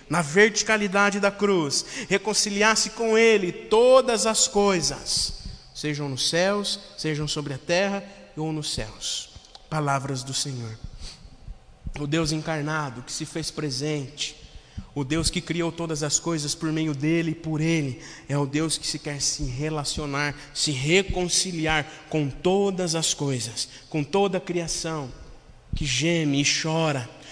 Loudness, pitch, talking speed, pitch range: -24 LUFS, 155 Hz, 145 wpm, 145-185 Hz